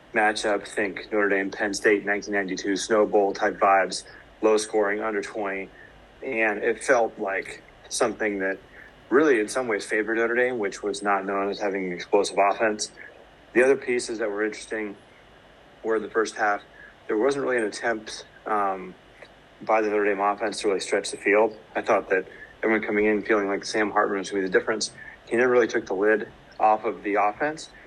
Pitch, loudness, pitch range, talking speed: 105 Hz, -24 LUFS, 100-110 Hz, 190 wpm